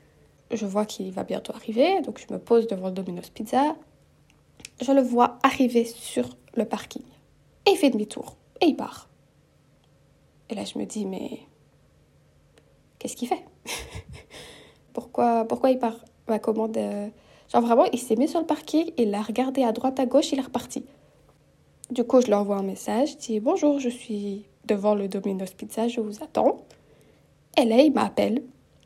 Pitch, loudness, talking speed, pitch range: 235 Hz, -25 LUFS, 175 wpm, 210-270 Hz